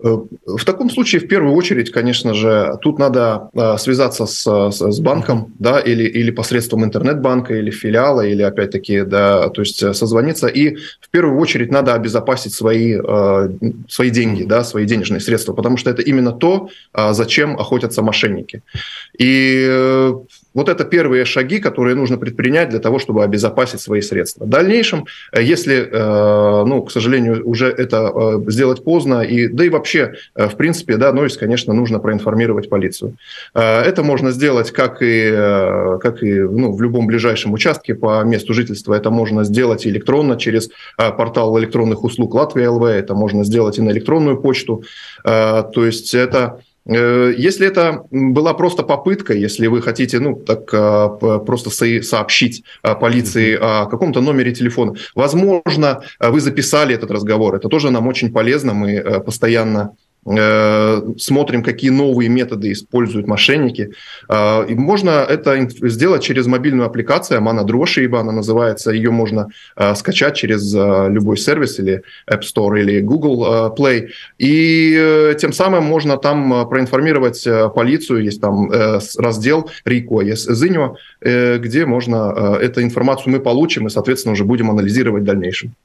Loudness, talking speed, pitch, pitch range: -14 LUFS, 150 wpm, 120 Hz, 110-130 Hz